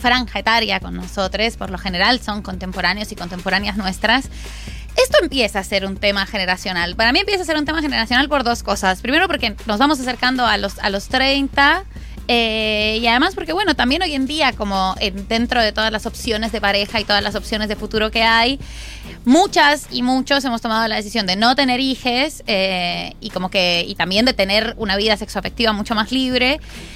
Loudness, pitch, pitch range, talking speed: -17 LUFS, 225 Hz, 200-255 Hz, 200 wpm